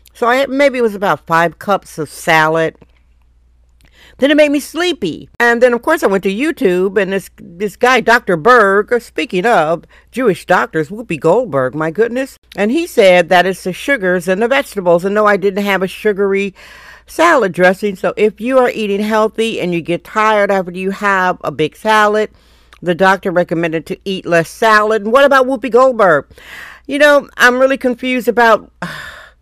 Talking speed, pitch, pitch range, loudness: 190 wpm, 205 Hz, 180-240 Hz, -13 LUFS